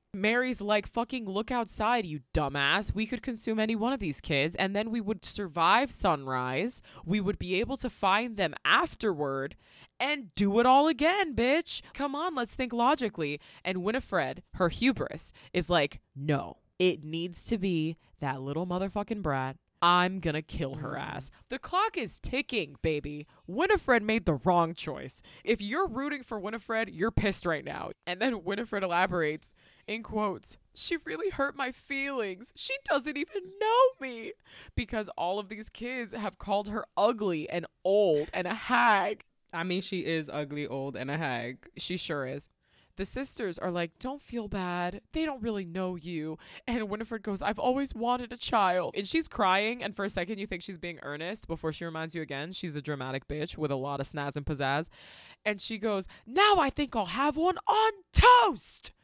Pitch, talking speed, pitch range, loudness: 205 Hz, 185 wpm, 165-245 Hz, -30 LUFS